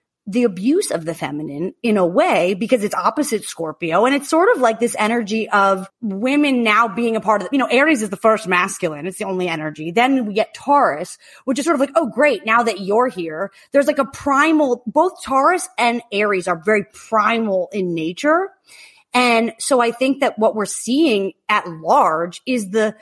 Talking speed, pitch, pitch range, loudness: 205 wpm, 225 Hz, 195-265 Hz, -18 LUFS